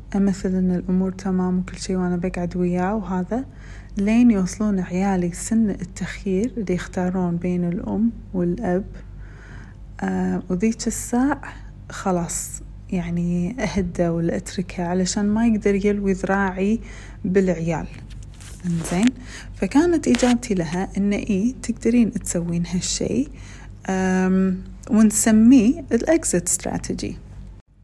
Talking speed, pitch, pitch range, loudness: 95 wpm, 185 Hz, 175-215 Hz, -21 LUFS